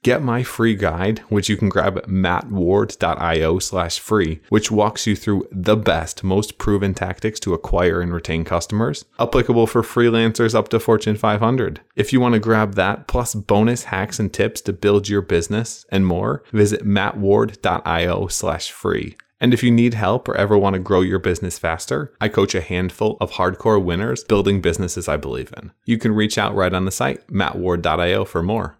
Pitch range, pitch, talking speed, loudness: 95-110 Hz, 105 Hz, 185 wpm, -19 LUFS